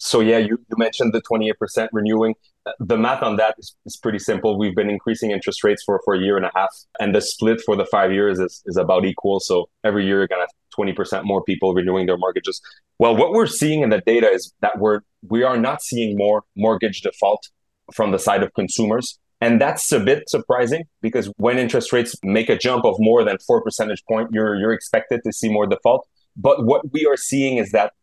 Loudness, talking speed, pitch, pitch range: -19 LUFS, 225 wpm, 110 Hz, 100-115 Hz